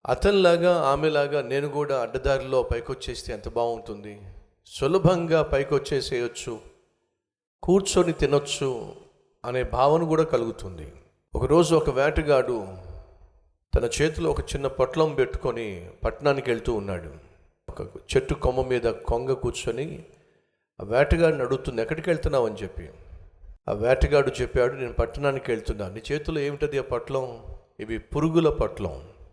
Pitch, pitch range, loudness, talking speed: 130 Hz, 100-150 Hz, -25 LUFS, 115 wpm